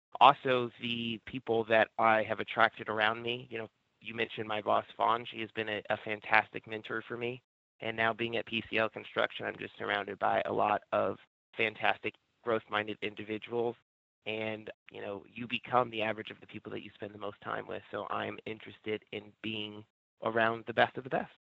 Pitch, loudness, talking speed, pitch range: 110 Hz, -33 LUFS, 195 wpm, 105-115 Hz